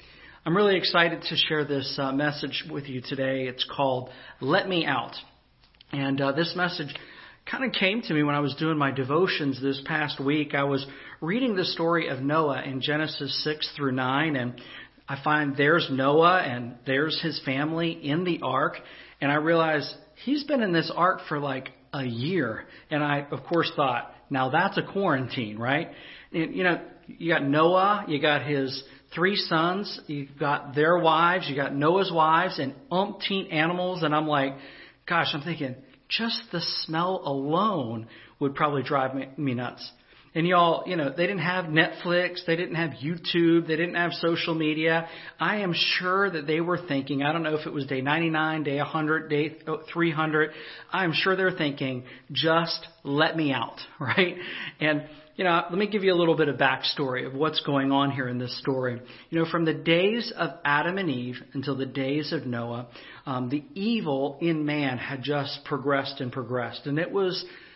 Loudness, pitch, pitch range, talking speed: -26 LUFS, 155 Hz, 140-170 Hz, 185 wpm